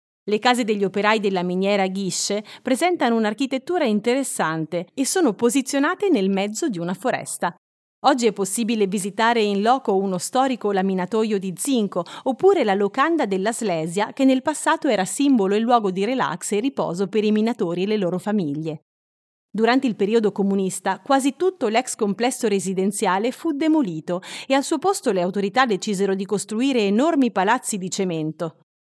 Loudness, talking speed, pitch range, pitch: -21 LUFS, 160 wpm, 195-260 Hz, 215 Hz